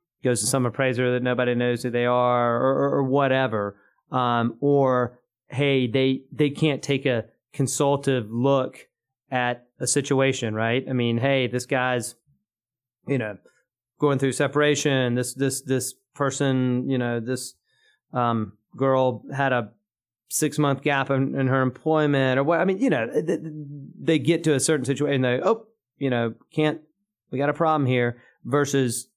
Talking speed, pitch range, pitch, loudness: 165 wpm, 125-145 Hz, 130 Hz, -23 LUFS